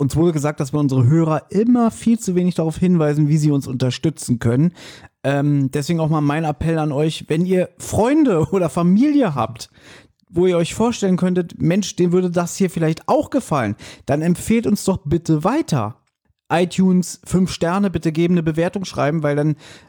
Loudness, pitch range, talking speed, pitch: -18 LUFS, 150-185 Hz, 185 wpm, 170 Hz